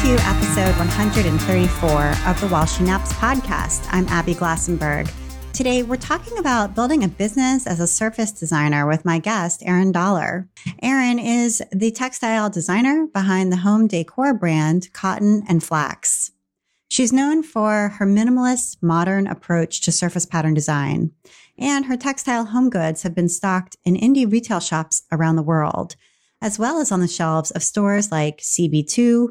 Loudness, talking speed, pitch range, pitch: -19 LUFS, 160 wpm, 165-230 Hz, 185 Hz